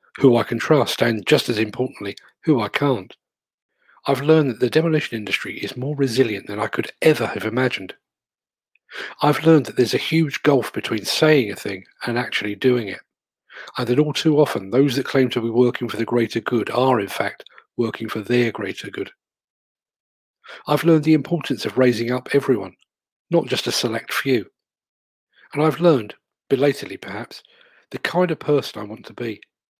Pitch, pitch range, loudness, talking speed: 130 Hz, 115-150 Hz, -20 LUFS, 180 wpm